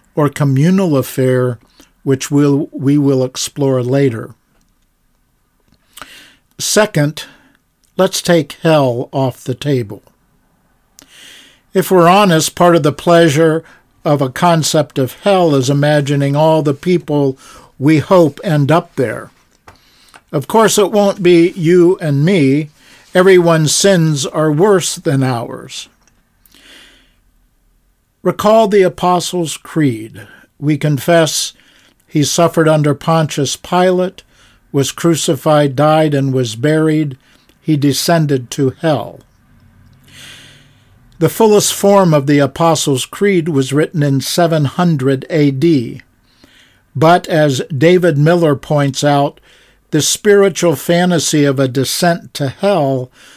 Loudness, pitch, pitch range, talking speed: -13 LUFS, 150 Hz, 135-170 Hz, 110 wpm